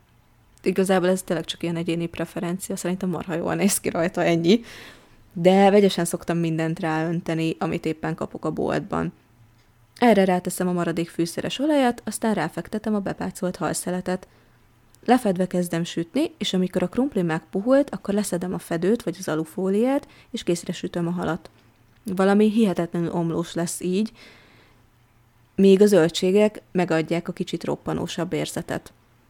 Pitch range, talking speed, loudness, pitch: 165-195 Hz, 140 wpm, -23 LUFS, 175 Hz